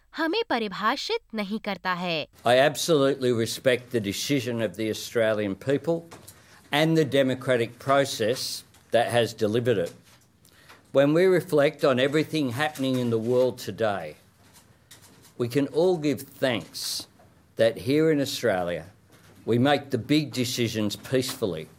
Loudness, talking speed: -25 LUFS, 115 wpm